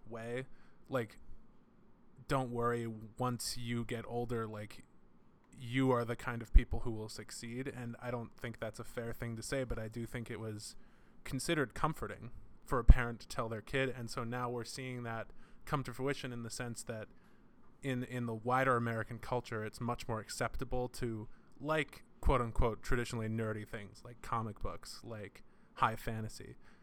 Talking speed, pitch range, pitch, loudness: 175 wpm, 115-125 Hz, 120 Hz, -39 LUFS